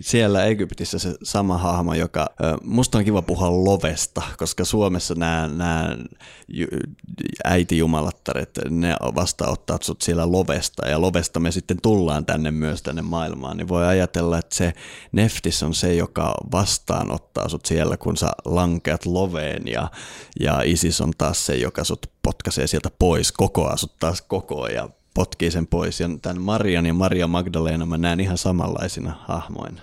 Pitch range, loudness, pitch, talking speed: 80-90 Hz, -22 LUFS, 85 Hz, 155 wpm